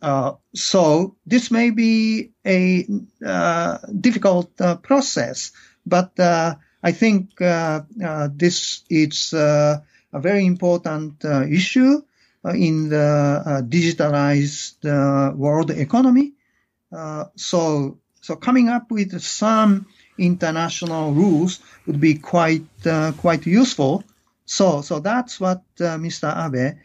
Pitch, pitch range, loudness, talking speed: 175 Hz, 155-200 Hz, -19 LUFS, 120 wpm